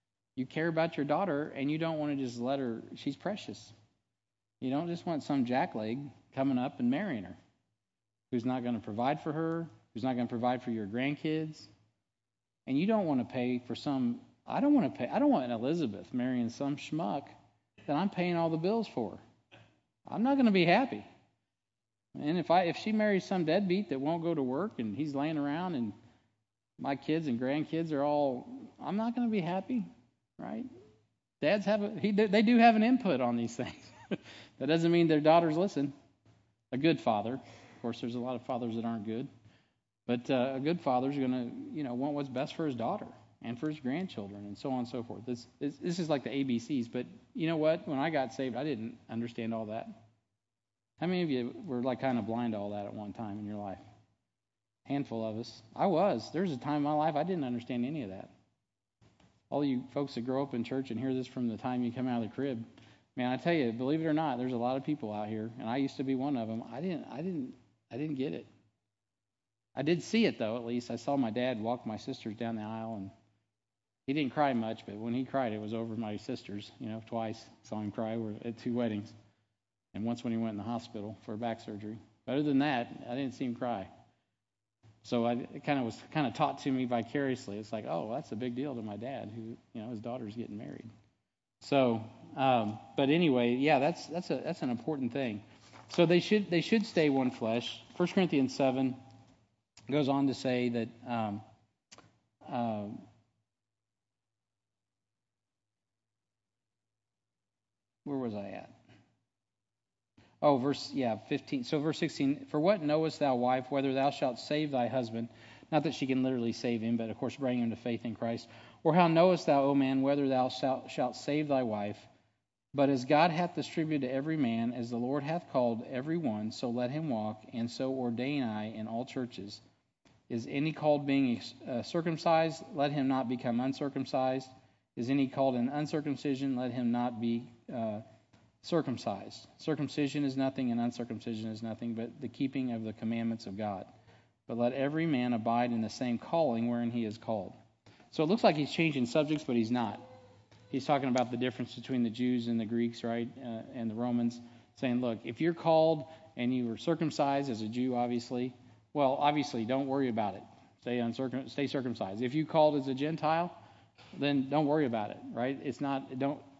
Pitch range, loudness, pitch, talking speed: 115-145 Hz, -33 LUFS, 125 Hz, 210 wpm